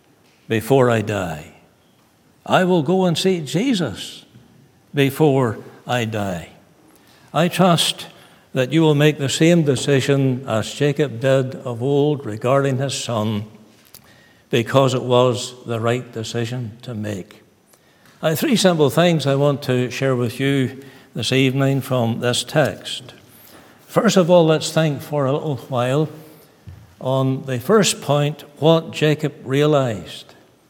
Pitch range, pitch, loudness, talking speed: 120-155 Hz, 135 Hz, -19 LUFS, 135 wpm